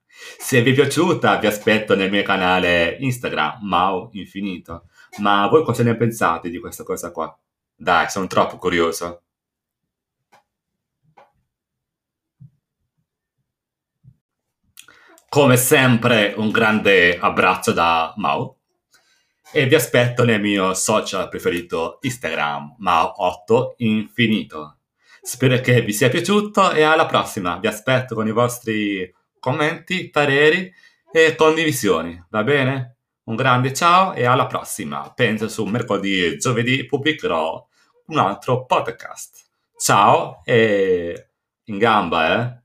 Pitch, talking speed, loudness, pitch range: 120 Hz, 115 wpm, -18 LUFS, 100-150 Hz